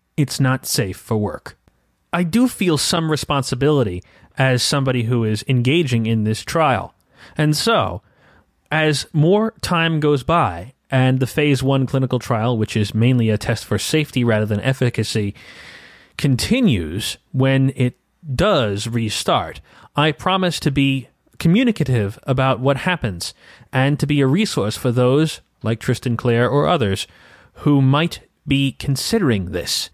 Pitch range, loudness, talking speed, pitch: 115-150 Hz, -19 LUFS, 140 wpm, 130 Hz